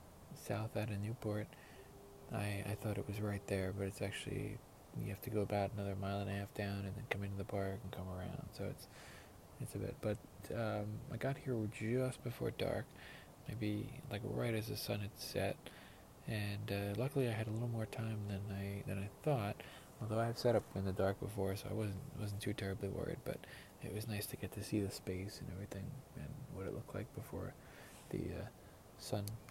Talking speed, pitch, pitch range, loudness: 215 wpm, 105 Hz, 100-115 Hz, -43 LUFS